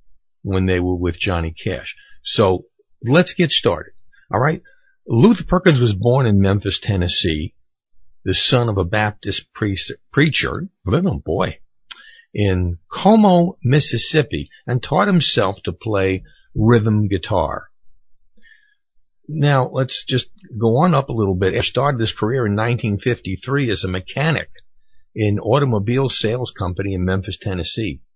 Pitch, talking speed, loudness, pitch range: 115 Hz, 135 wpm, -18 LUFS, 95-145 Hz